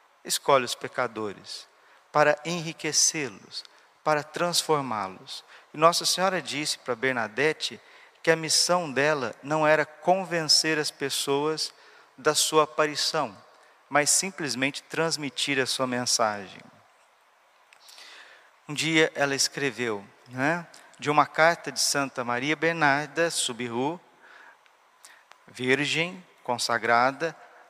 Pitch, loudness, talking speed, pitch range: 150 Hz, -25 LUFS, 100 wpm, 135-165 Hz